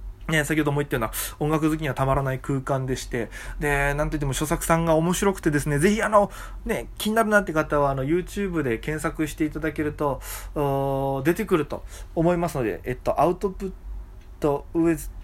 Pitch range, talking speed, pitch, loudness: 135-165 Hz, 415 characters per minute, 150 Hz, -24 LUFS